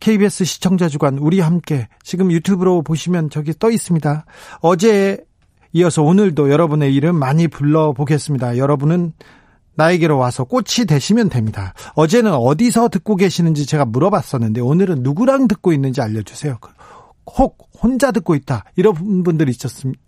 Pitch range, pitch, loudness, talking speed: 140-190 Hz, 160 Hz, -16 LUFS, 370 characters per minute